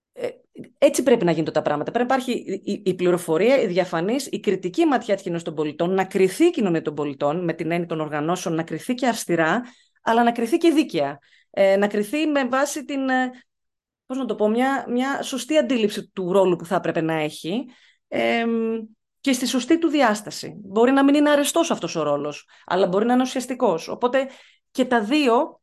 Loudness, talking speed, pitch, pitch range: -22 LUFS, 195 wpm, 225 Hz, 175-265 Hz